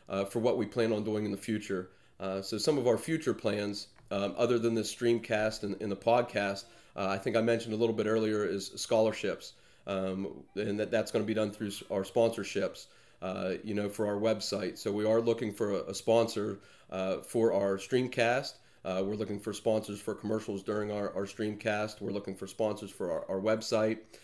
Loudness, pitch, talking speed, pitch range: -32 LUFS, 105 Hz, 215 wpm, 100-115 Hz